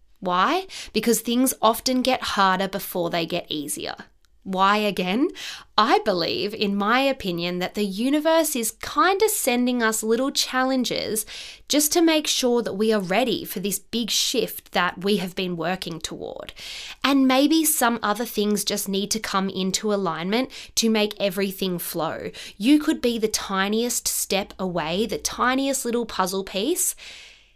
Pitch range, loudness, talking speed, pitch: 195-255 Hz, -22 LUFS, 155 wpm, 220 Hz